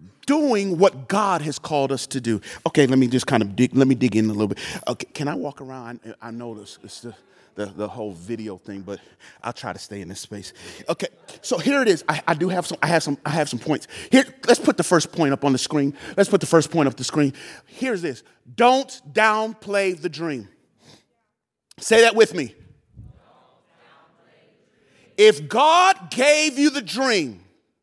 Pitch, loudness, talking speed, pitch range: 150 Hz, -20 LUFS, 205 wpm, 120-200 Hz